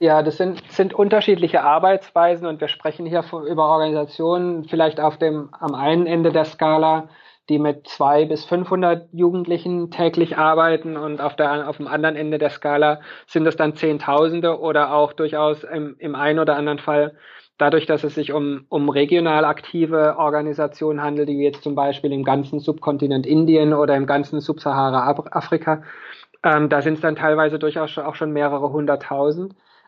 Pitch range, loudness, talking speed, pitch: 150-165 Hz, -19 LUFS, 175 wpm, 155 Hz